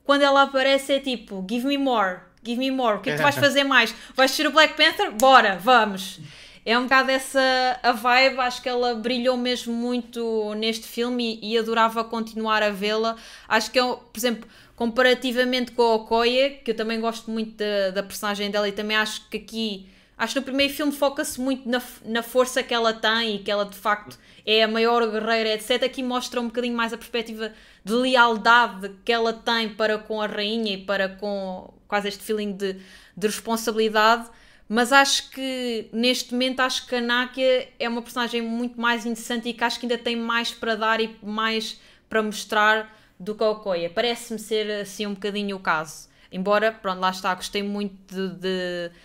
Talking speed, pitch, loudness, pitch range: 200 wpm, 230 Hz, -22 LUFS, 215-250 Hz